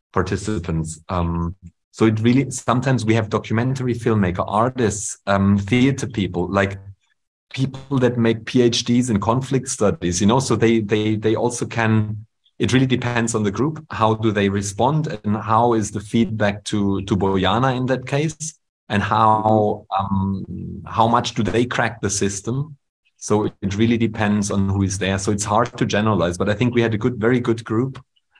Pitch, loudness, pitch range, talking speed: 110 Hz, -20 LUFS, 100-120 Hz, 180 wpm